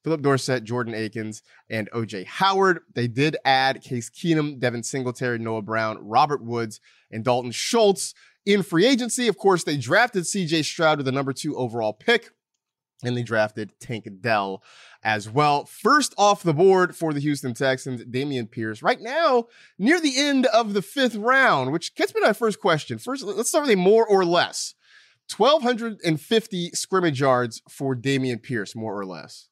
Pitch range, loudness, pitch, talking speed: 120-200 Hz, -22 LUFS, 145 Hz, 175 wpm